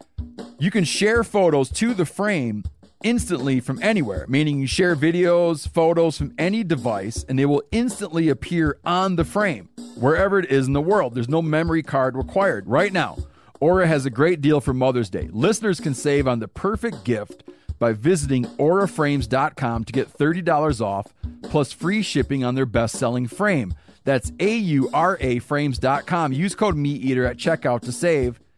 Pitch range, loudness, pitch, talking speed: 130-180 Hz, -21 LUFS, 145 Hz, 170 wpm